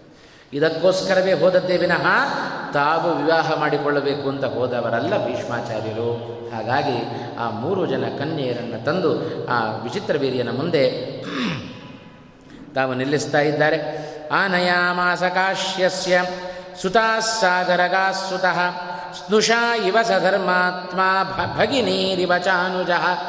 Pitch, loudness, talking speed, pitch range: 180 Hz, -20 LUFS, 80 wpm, 145-185 Hz